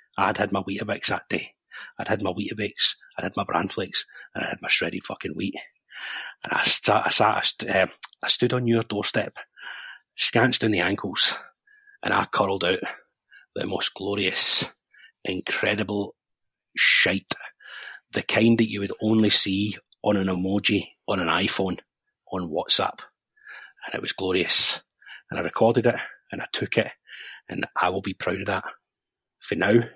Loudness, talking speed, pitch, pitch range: -23 LUFS, 170 wpm, 105 Hz, 100-115 Hz